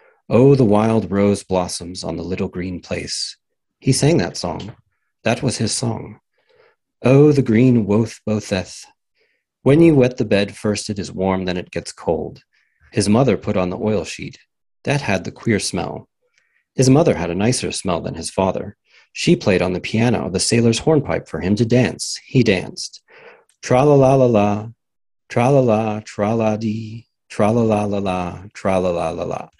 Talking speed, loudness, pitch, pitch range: 160 wpm, -18 LUFS, 110 Hz, 100-125 Hz